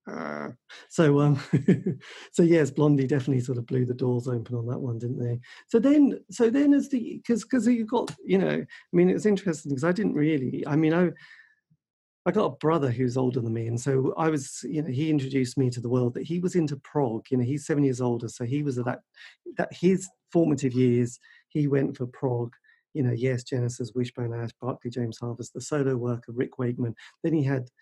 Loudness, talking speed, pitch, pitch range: -26 LUFS, 220 wpm, 135 Hz, 125-165 Hz